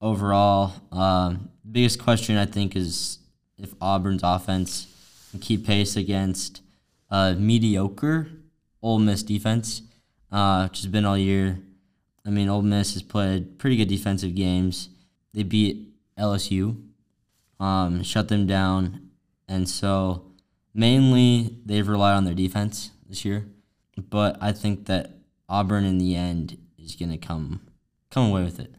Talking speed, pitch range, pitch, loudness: 145 wpm, 95-105 Hz, 100 Hz, -24 LUFS